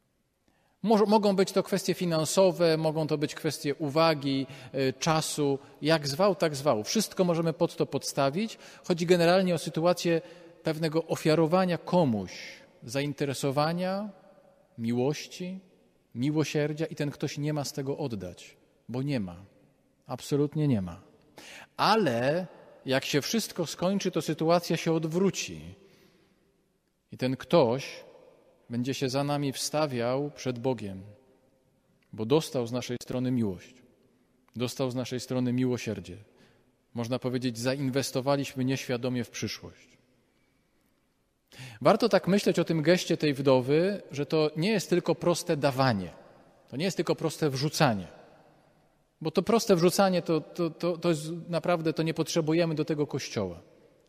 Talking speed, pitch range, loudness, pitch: 130 wpm, 130-175 Hz, -28 LUFS, 155 Hz